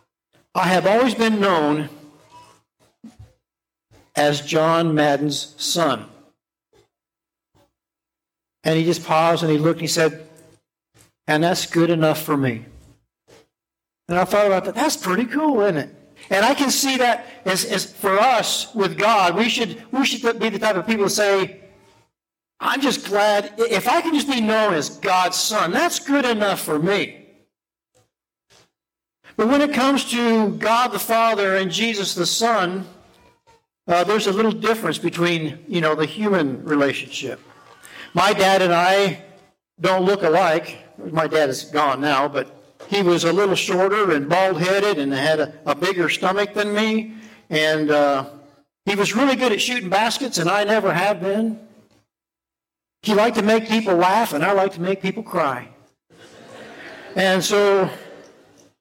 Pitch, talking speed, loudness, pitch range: 190 Hz, 160 wpm, -19 LUFS, 160-220 Hz